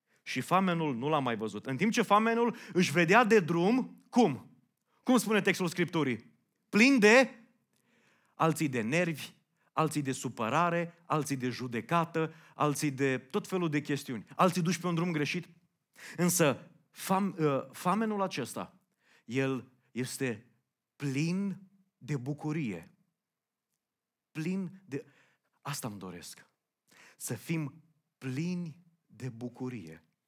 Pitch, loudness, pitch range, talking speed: 160 Hz, -31 LUFS, 135-185 Hz, 120 wpm